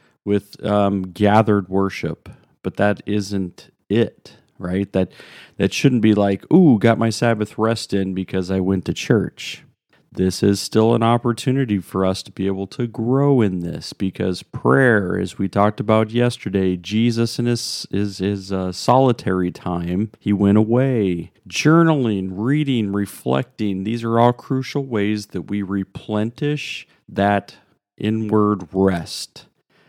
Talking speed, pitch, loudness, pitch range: 145 wpm, 105 Hz, -19 LUFS, 95-115 Hz